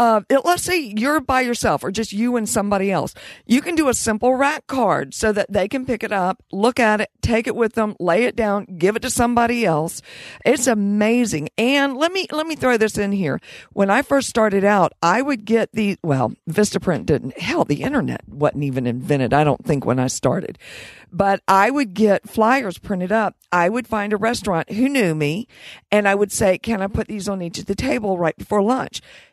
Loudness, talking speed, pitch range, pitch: -19 LUFS, 220 wpm, 185-240 Hz, 210 Hz